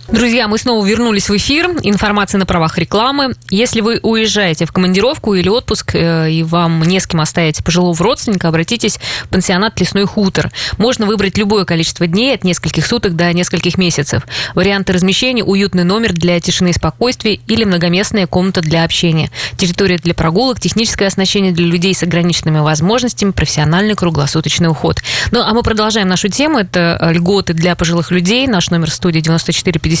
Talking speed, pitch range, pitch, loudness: 165 wpm, 170-210 Hz, 185 Hz, -12 LUFS